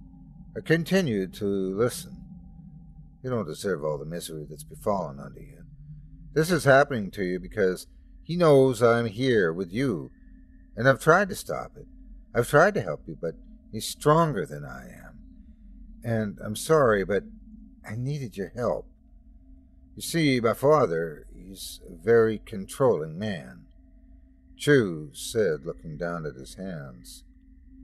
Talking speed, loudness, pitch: 145 wpm, -25 LUFS, 120 Hz